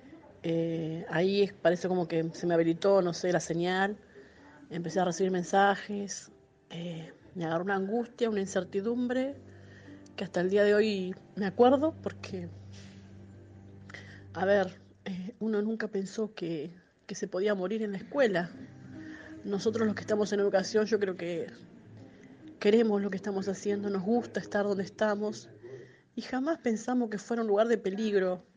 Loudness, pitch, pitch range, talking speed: -30 LUFS, 195 Hz, 170-215 Hz, 155 wpm